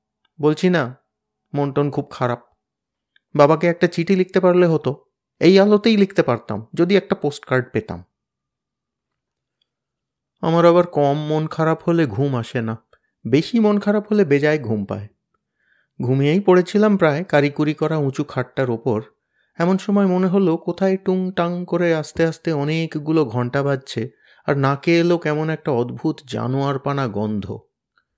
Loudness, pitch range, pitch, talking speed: -19 LUFS, 130-175 Hz, 150 Hz, 140 wpm